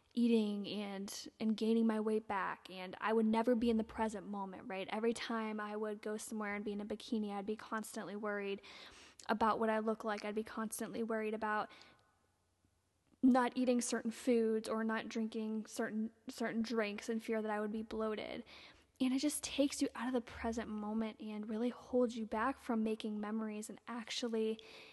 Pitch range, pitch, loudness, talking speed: 210-230 Hz, 220 Hz, -39 LUFS, 190 wpm